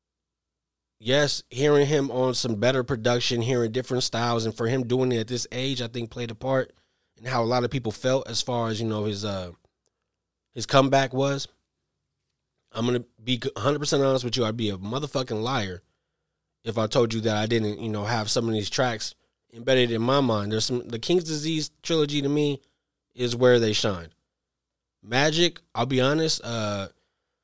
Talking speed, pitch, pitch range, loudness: 190 wpm, 120 Hz, 110-135 Hz, -25 LUFS